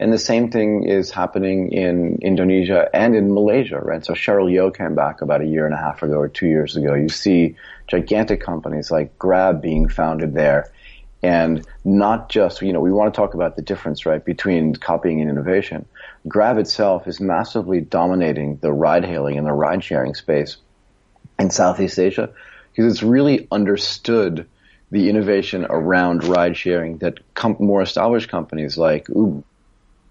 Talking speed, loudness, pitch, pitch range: 165 wpm, -18 LUFS, 90 Hz, 80-100 Hz